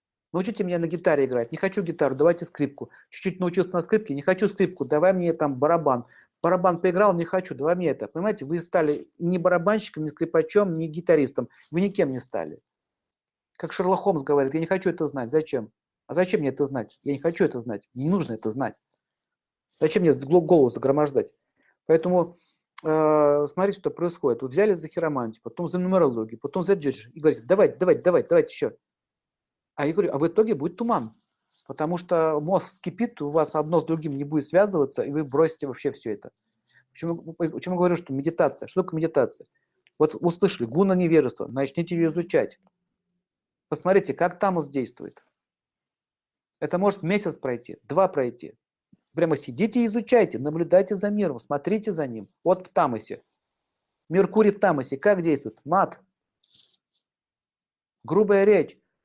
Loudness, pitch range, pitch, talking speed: -24 LUFS, 145-190 Hz, 170 Hz, 165 wpm